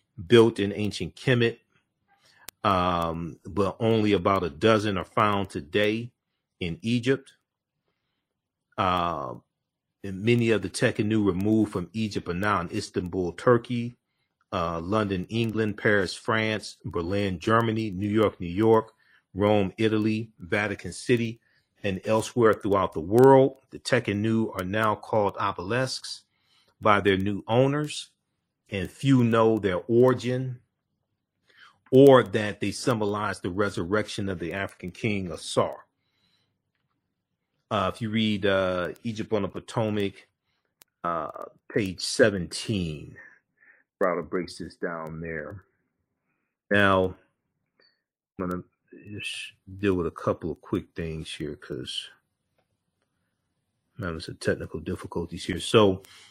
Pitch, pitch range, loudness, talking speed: 105 Hz, 95-115 Hz, -26 LUFS, 120 wpm